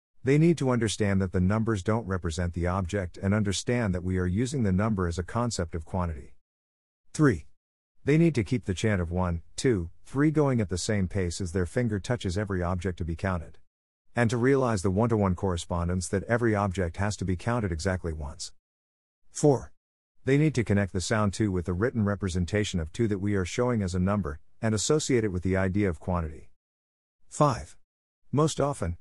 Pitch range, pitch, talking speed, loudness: 90-115 Hz, 95 Hz, 205 wpm, -28 LUFS